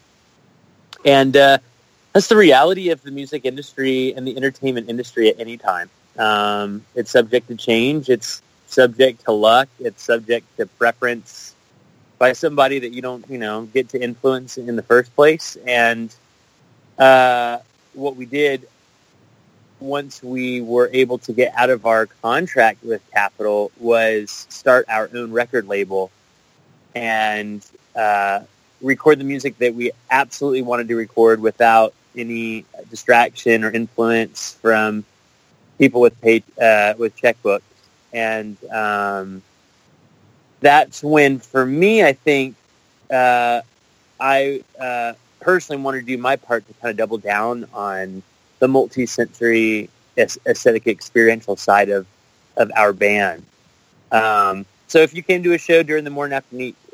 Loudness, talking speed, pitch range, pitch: -17 LUFS, 140 wpm, 110-135 Hz, 120 Hz